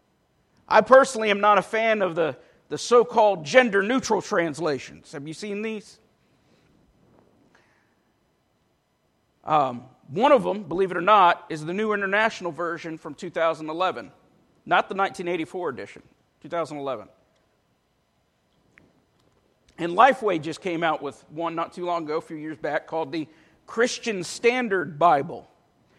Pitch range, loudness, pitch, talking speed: 160-215 Hz, -23 LUFS, 180 Hz, 135 wpm